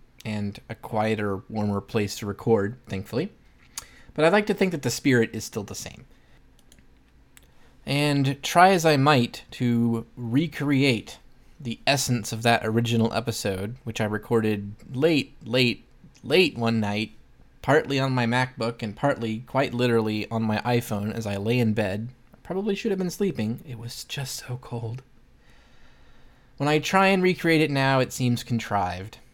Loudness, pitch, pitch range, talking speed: -24 LUFS, 120 Hz, 110-135 Hz, 160 wpm